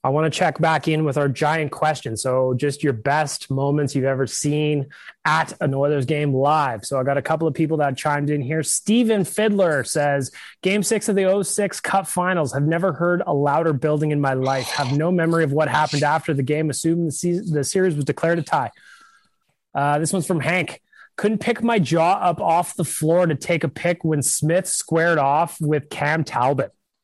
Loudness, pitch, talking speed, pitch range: -20 LUFS, 155 Hz, 210 wpm, 145-175 Hz